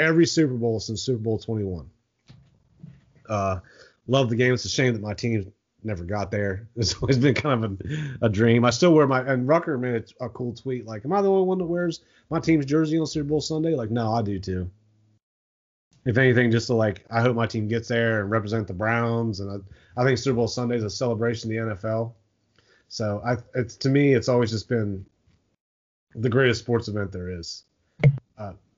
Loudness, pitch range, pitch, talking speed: -24 LUFS, 110-130 Hz, 115 Hz, 215 wpm